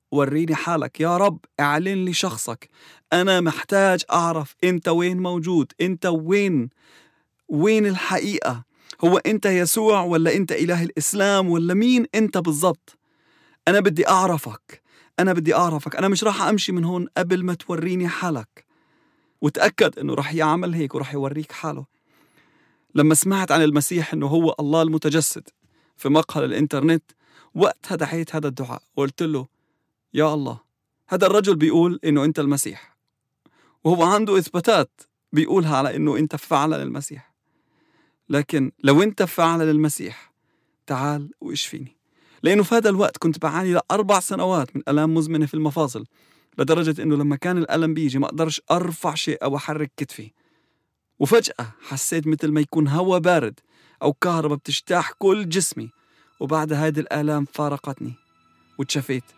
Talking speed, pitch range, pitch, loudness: 135 wpm, 150-180 Hz, 160 Hz, -21 LUFS